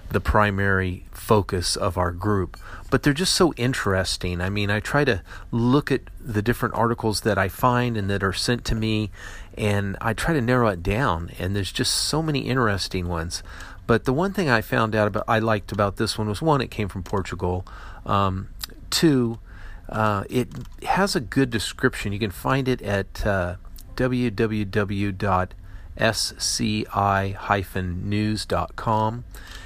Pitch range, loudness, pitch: 95-120 Hz, -23 LUFS, 105 Hz